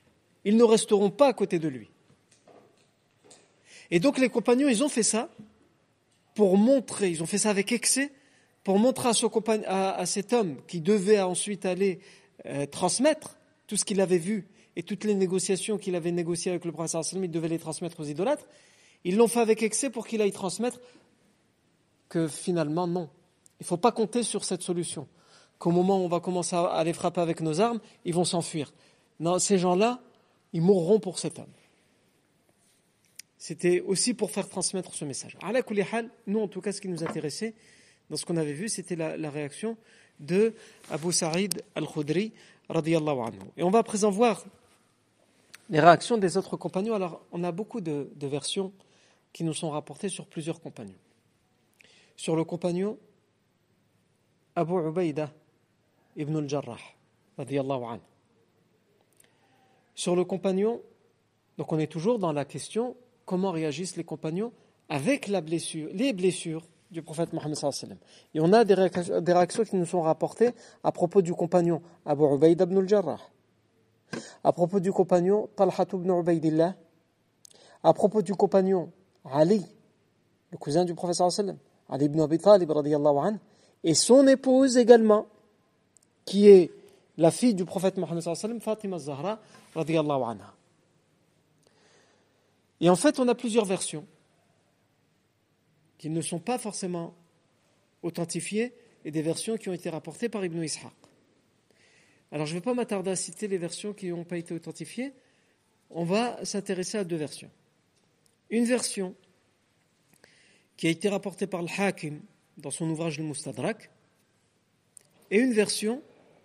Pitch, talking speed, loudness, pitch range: 180 Hz, 160 wpm, -27 LUFS, 165-210 Hz